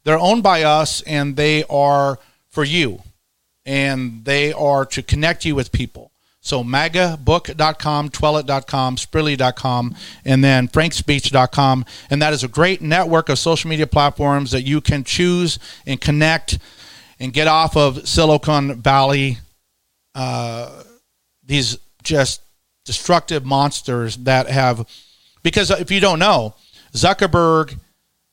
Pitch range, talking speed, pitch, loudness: 130-155 Hz, 125 wpm, 140 Hz, -17 LUFS